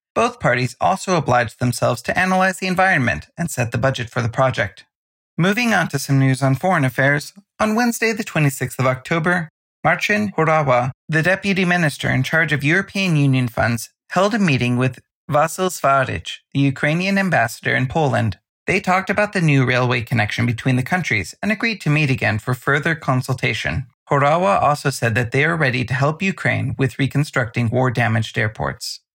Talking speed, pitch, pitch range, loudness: 175 wpm, 140 Hz, 125-180 Hz, -18 LUFS